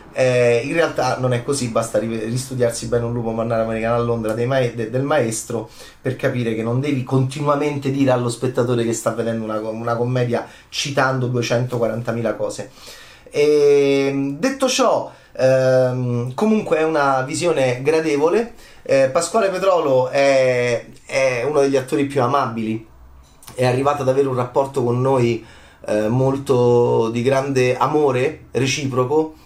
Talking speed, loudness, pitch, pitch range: 145 wpm, -19 LUFS, 125 Hz, 115-140 Hz